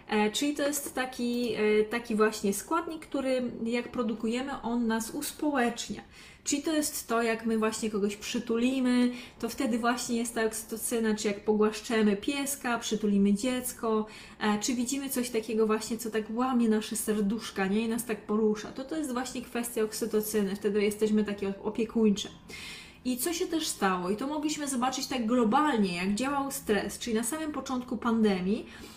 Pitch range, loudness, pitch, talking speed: 215-255 Hz, -30 LUFS, 230 Hz, 160 wpm